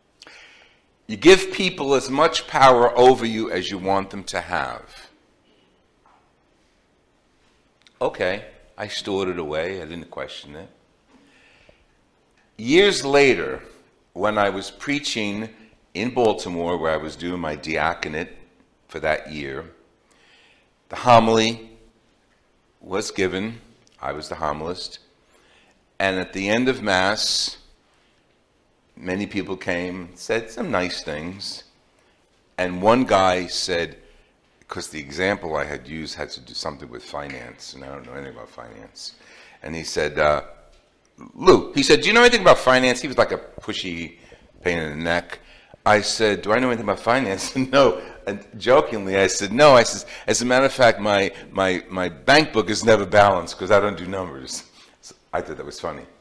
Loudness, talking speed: -20 LUFS, 155 wpm